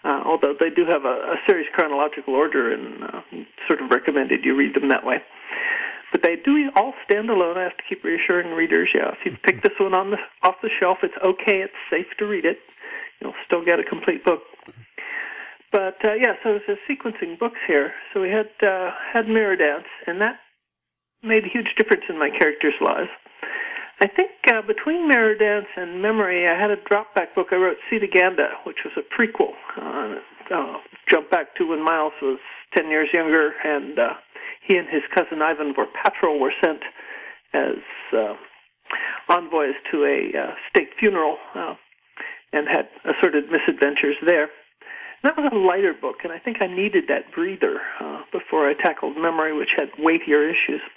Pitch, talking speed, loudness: 210 Hz, 185 wpm, -21 LUFS